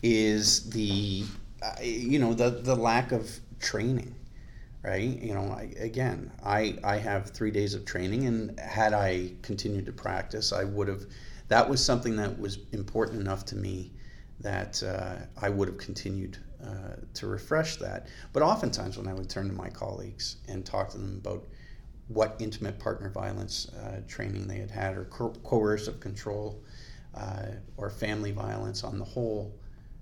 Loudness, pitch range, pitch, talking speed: -31 LUFS, 95-115 Hz, 105 Hz, 165 wpm